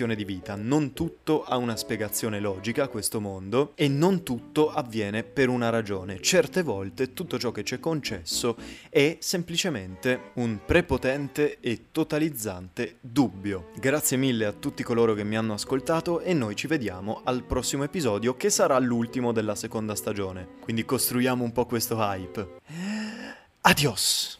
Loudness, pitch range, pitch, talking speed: -27 LUFS, 110-145 Hz, 125 Hz, 150 wpm